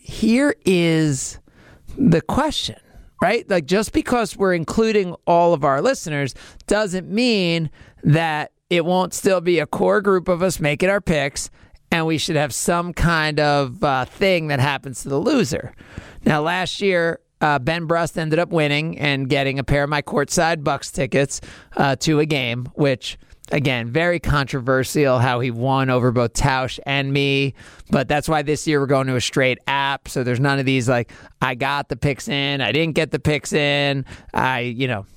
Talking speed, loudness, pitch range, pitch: 185 wpm, -20 LUFS, 135-170 Hz, 145 Hz